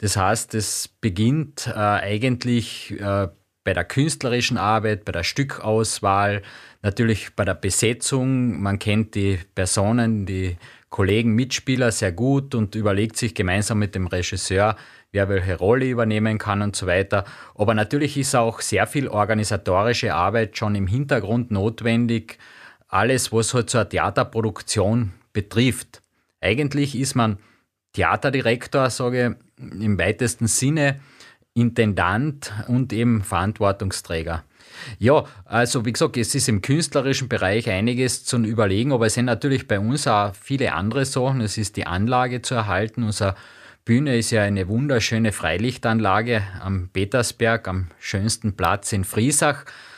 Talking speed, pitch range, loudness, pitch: 140 wpm, 100-125 Hz, -21 LUFS, 110 Hz